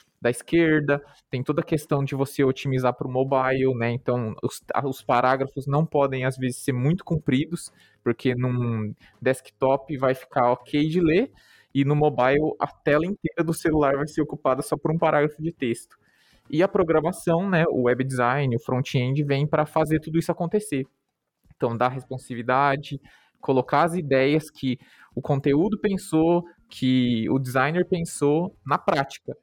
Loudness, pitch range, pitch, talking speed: -24 LUFS, 130-160 Hz, 140 Hz, 165 wpm